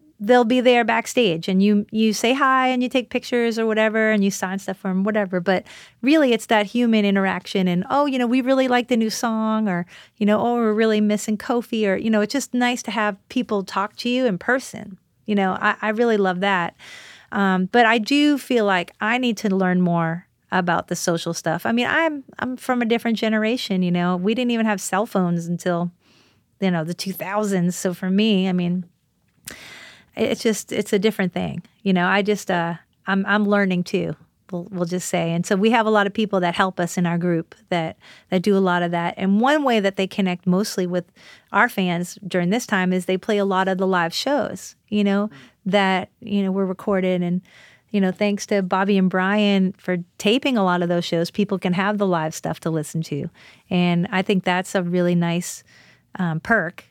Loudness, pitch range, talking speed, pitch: -21 LUFS, 180-225 Hz, 220 wpm, 200 Hz